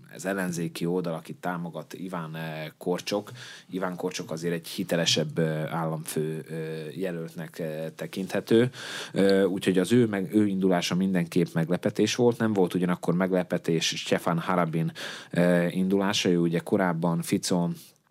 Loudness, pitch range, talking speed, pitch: -27 LUFS, 80-95 Hz, 115 wpm, 90 Hz